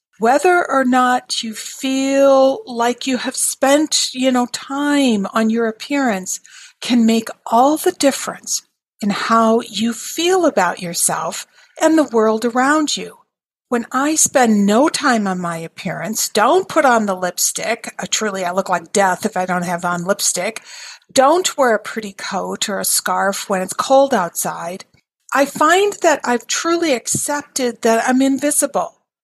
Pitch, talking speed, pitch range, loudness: 245 Hz, 160 wpm, 215-280 Hz, -16 LUFS